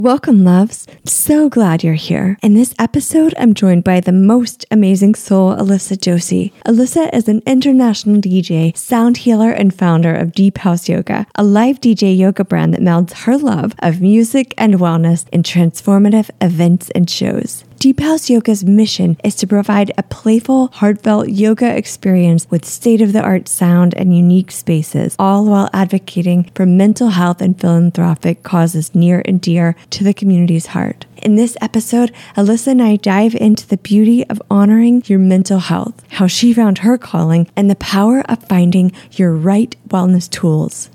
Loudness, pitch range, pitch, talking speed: -12 LUFS, 180-225 Hz, 200 Hz, 170 wpm